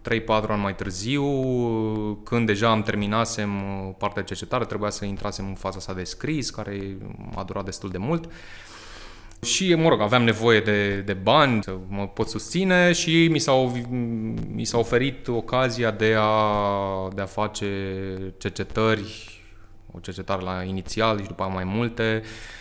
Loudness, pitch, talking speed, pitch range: -24 LUFS, 105 Hz, 155 wpm, 95-115 Hz